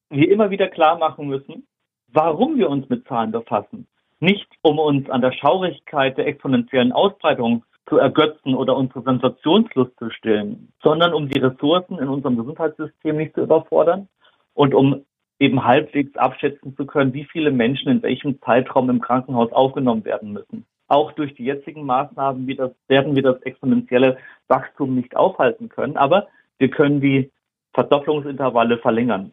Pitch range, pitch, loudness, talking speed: 130-155 Hz, 135 Hz, -19 LUFS, 160 wpm